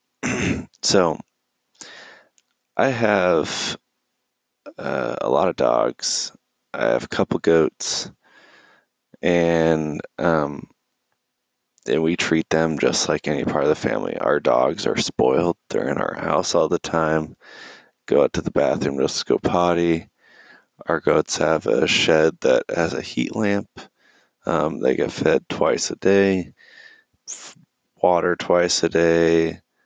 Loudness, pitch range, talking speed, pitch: -21 LUFS, 80-90 Hz, 135 wpm, 85 Hz